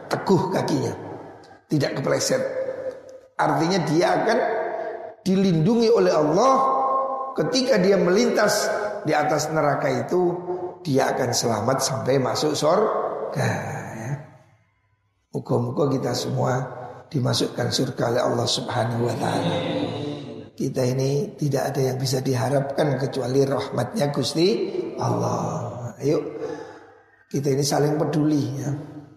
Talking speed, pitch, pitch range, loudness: 105 wpm, 150 Hz, 135-225 Hz, -23 LUFS